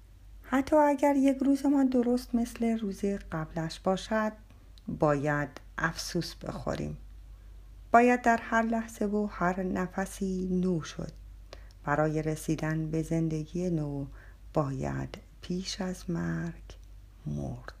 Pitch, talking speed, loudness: 165 Hz, 110 wpm, -30 LUFS